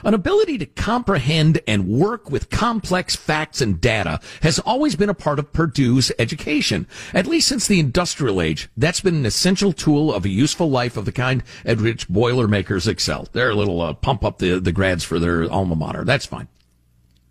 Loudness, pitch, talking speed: -19 LUFS, 125 Hz, 195 wpm